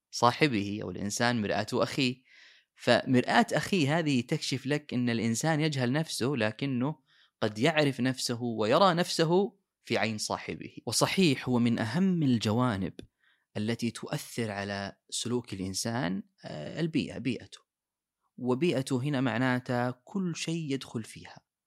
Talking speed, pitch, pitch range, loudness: 115 wpm, 125 Hz, 115-155 Hz, -29 LUFS